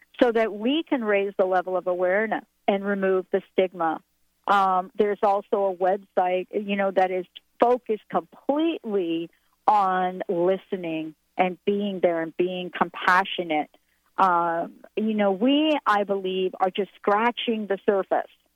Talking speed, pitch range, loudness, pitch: 140 wpm, 185-210 Hz, -24 LUFS, 195 Hz